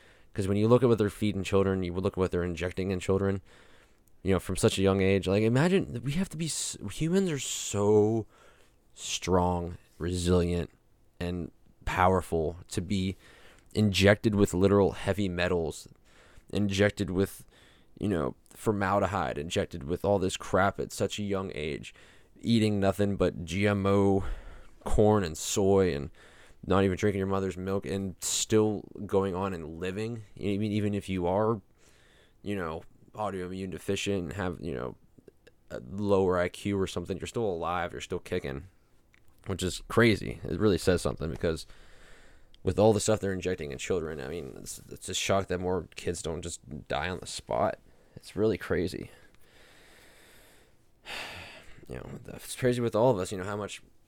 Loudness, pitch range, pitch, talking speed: -29 LUFS, 90-105 Hz, 95 Hz, 165 wpm